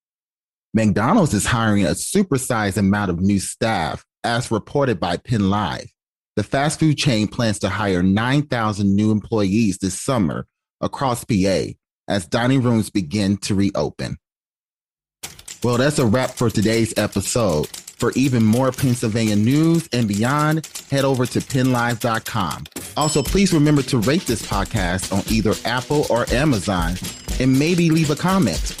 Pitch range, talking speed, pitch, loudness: 105-135 Hz, 140 wpm, 115 Hz, -19 LUFS